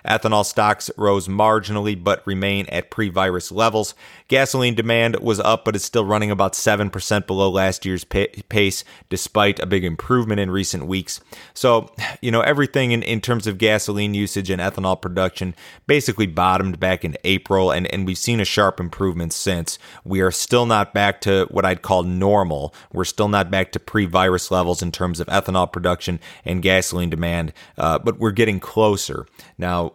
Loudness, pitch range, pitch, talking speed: -20 LUFS, 95-110 Hz, 100 Hz, 180 wpm